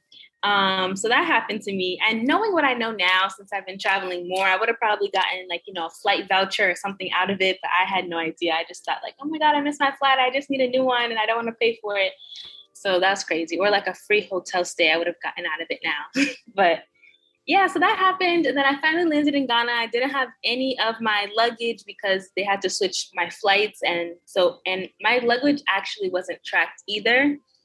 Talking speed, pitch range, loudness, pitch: 250 wpm, 185-255 Hz, -22 LUFS, 205 Hz